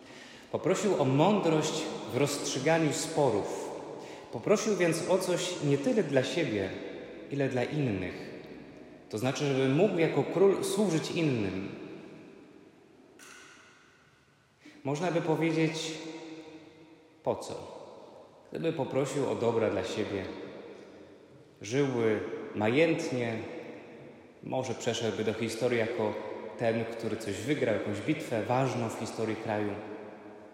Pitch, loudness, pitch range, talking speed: 145 Hz, -30 LUFS, 115-165 Hz, 105 wpm